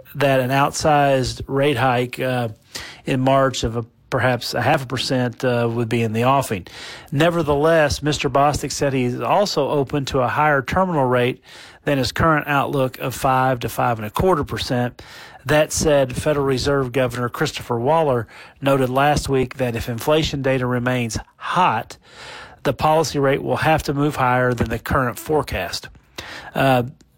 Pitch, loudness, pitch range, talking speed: 135 Hz, -19 LUFS, 125-145 Hz, 165 wpm